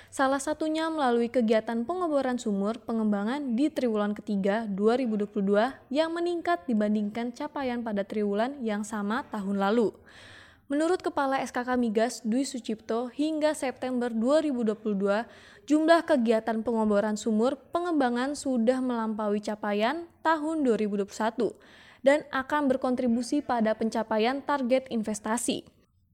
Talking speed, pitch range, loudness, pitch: 110 wpm, 220-275 Hz, -28 LUFS, 240 Hz